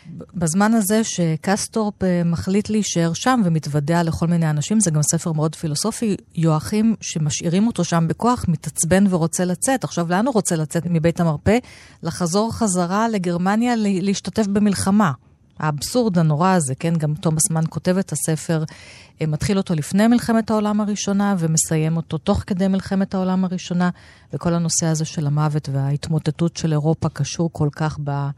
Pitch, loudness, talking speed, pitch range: 170 Hz, -20 LUFS, 145 wpm, 160-200 Hz